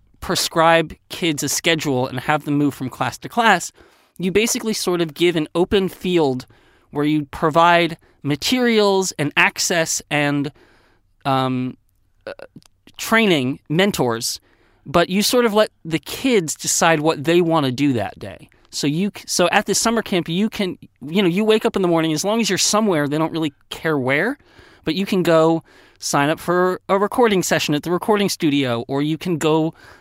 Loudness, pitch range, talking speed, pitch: -19 LUFS, 145-190 Hz, 180 wpm, 165 Hz